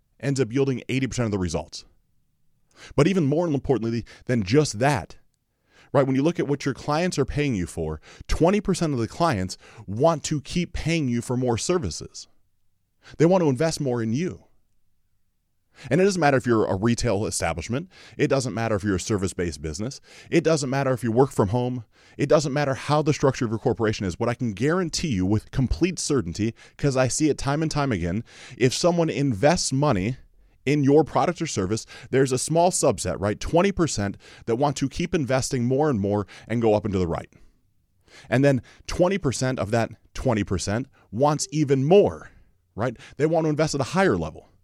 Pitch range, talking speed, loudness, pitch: 105-145 Hz, 190 wpm, -24 LUFS, 130 Hz